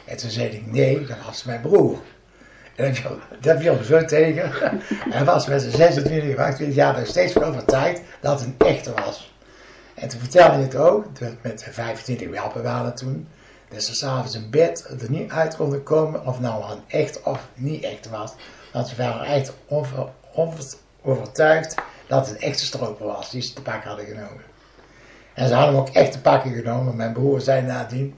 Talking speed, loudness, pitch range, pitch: 195 wpm, -21 LUFS, 115-145 Hz, 130 Hz